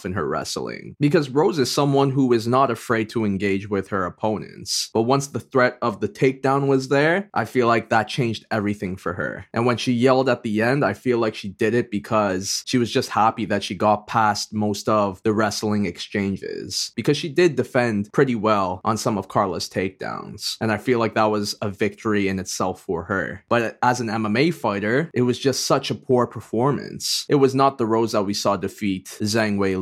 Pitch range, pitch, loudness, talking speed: 105-130 Hz, 115 Hz, -22 LUFS, 215 wpm